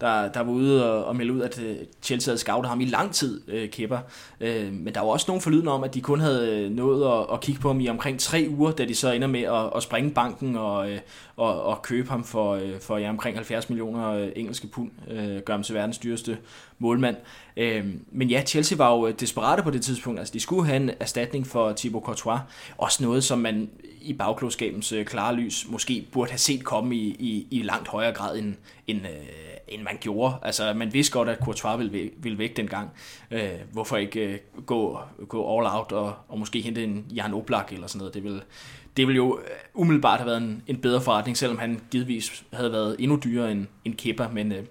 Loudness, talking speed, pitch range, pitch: -26 LUFS, 220 wpm, 110-125 Hz, 115 Hz